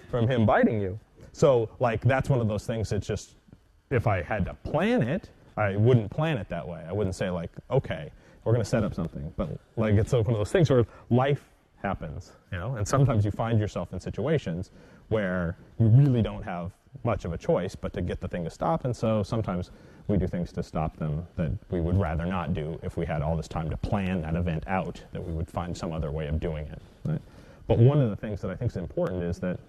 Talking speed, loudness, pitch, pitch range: 240 wpm, -28 LUFS, 100 Hz, 85-115 Hz